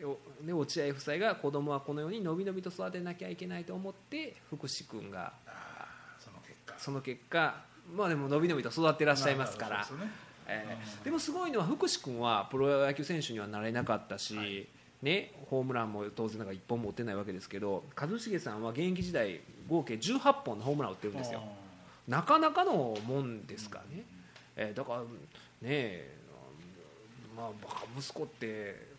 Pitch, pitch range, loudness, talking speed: 140 Hz, 115-170 Hz, -35 LUFS, 330 characters per minute